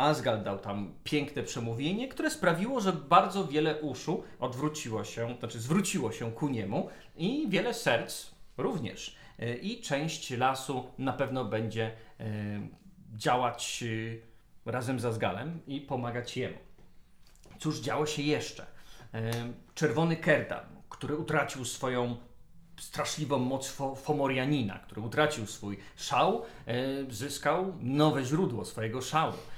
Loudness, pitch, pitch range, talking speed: -32 LUFS, 130 Hz, 115-150 Hz, 115 wpm